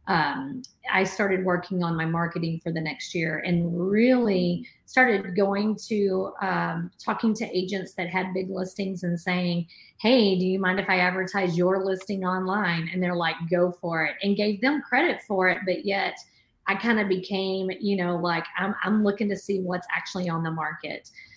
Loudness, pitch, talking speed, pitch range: -25 LUFS, 185 Hz, 190 wpm, 175-200 Hz